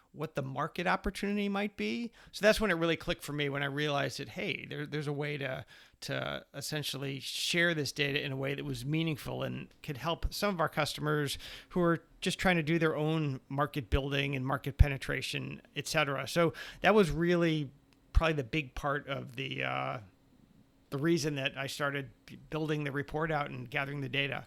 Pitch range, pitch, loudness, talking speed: 140-165 Hz, 145 Hz, -33 LUFS, 200 wpm